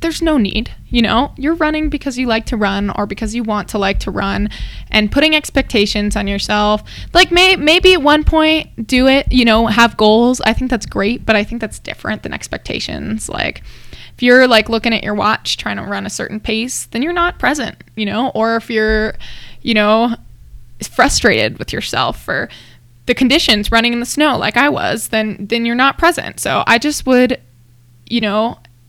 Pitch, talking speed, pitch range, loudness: 230 Hz, 200 wpm, 210-260 Hz, -14 LUFS